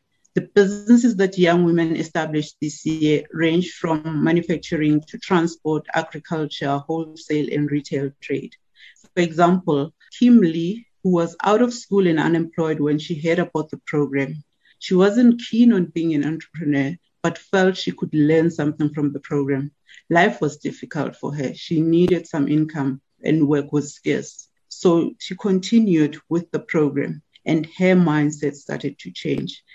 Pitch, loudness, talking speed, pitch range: 160 Hz, -20 LUFS, 155 wpm, 150-180 Hz